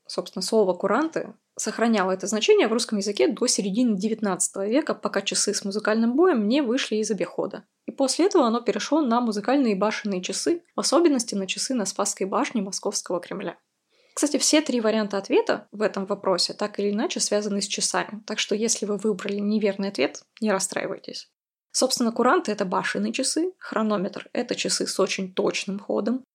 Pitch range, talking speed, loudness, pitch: 200-250 Hz, 170 wpm, -24 LUFS, 215 Hz